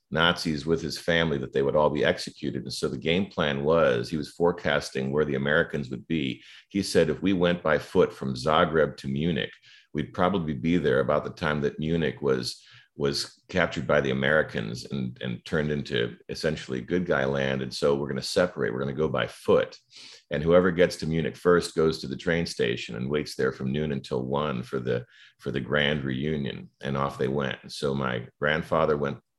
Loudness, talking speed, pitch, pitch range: -27 LUFS, 210 wpm, 75 Hz, 65-80 Hz